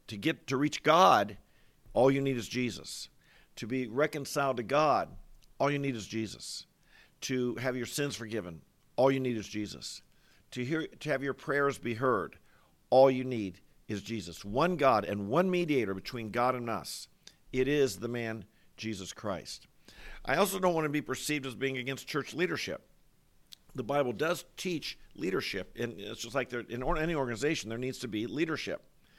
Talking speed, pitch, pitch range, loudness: 180 wpm, 130 Hz, 110-140 Hz, -32 LUFS